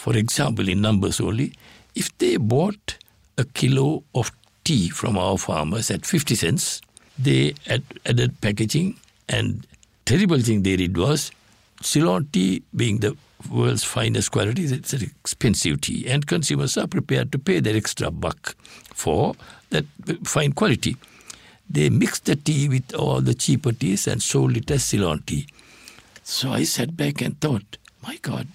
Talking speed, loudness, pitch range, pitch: 160 wpm, -22 LUFS, 100-145 Hz, 120 Hz